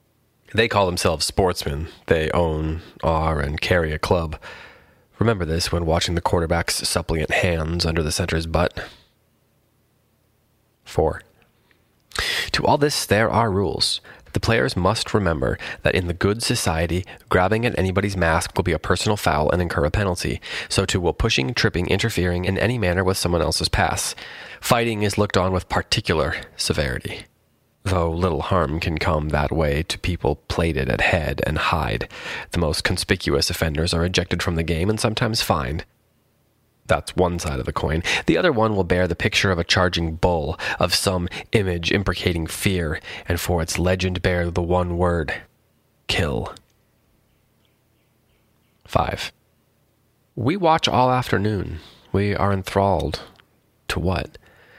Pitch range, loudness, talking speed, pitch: 85-110 Hz, -21 LUFS, 150 wpm, 90 Hz